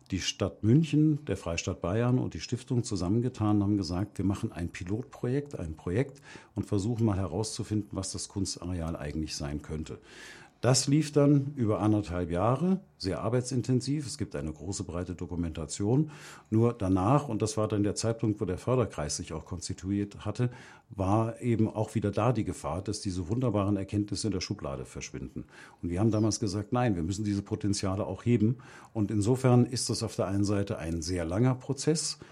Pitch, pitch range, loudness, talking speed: 105 Hz, 95-120 Hz, -30 LUFS, 180 wpm